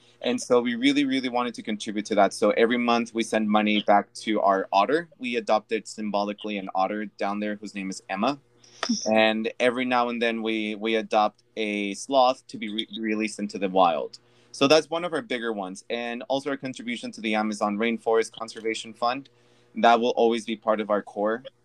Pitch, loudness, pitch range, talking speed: 115 Hz, -25 LUFS, 105-125 Hz, 200 wpm